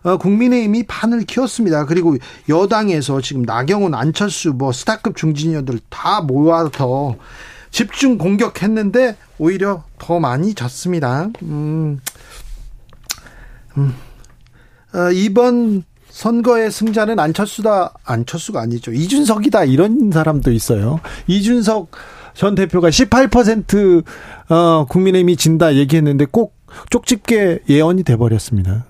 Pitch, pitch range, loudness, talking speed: 175 Hz, 140-215 Hz, -15 LUFS, 260 characters per minute